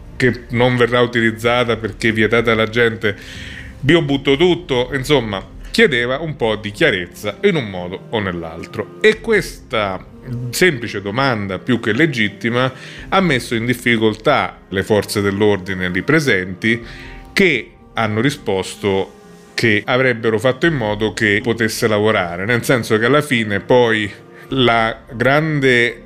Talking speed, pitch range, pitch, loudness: 130 wpm, 105-130 Hz, 115 Hz, -16 LUFS